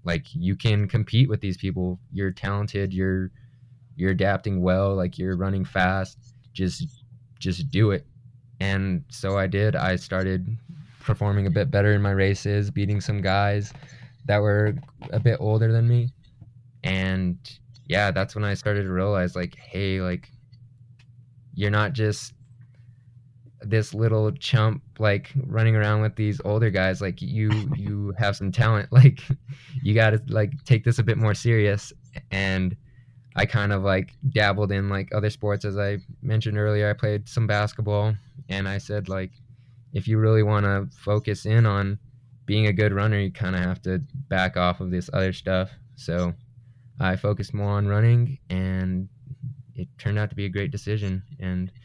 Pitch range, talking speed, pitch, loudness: 100-120 Hz, 170 wpm, 105 Hz, -24 LUFS